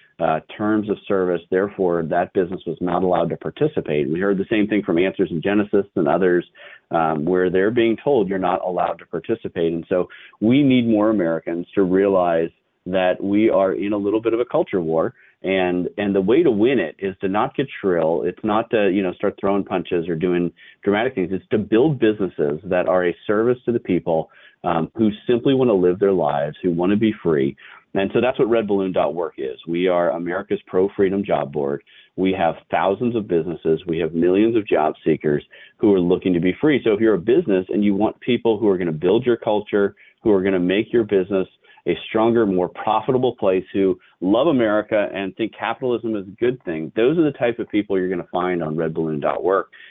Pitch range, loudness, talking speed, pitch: 90-105 Hz, -20 LUFS, 220 wpm, 95 Hz